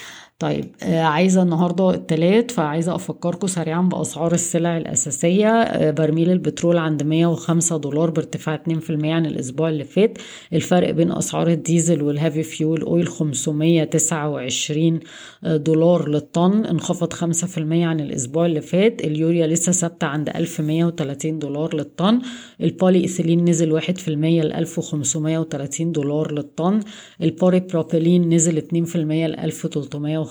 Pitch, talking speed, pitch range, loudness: 165 Hz, 120 wpm, 155-170 Hz, -20 LUFS